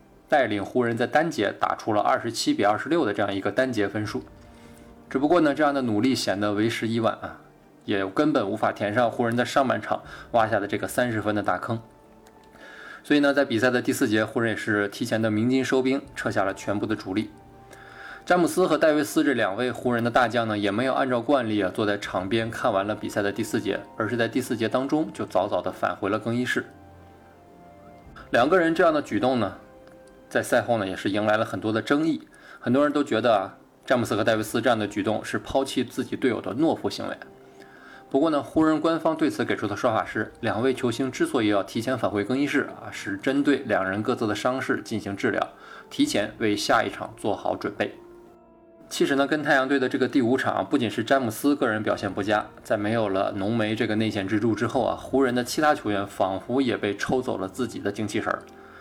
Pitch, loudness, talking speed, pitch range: 115 Hz, -25 LUFS, 325 characters per minute, 105-135 Hz